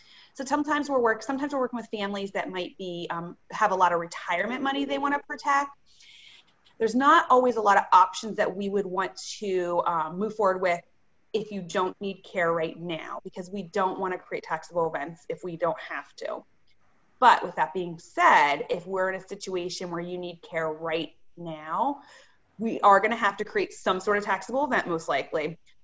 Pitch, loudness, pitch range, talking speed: 195 Hz, -26 LUFS, 175-235 Hz, 200 wpm